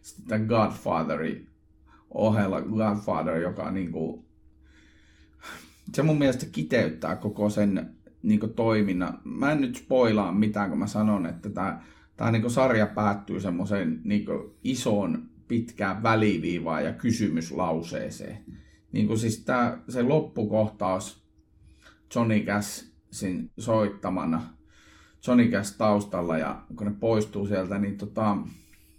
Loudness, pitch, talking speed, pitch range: -27 LUFS, 105 Hz, 110 wpm, 85-110 Hz